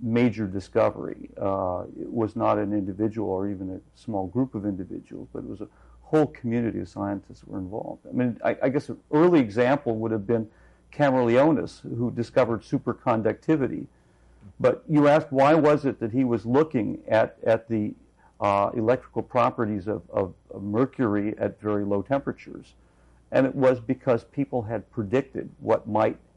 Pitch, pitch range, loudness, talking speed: 115 Hz, 100-130 Hz, -25 LUFS, 170 wpm